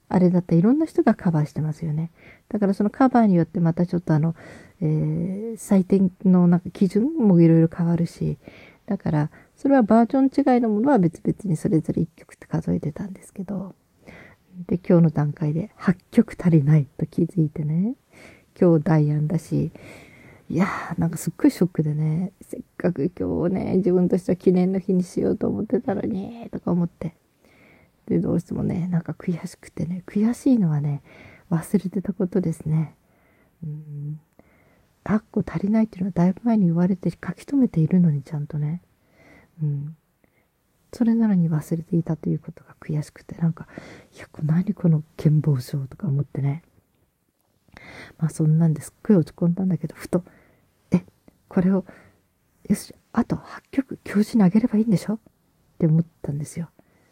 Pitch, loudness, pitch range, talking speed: 175 Hz, -22 LUFS, 160-200 Hz, 345 characters per minute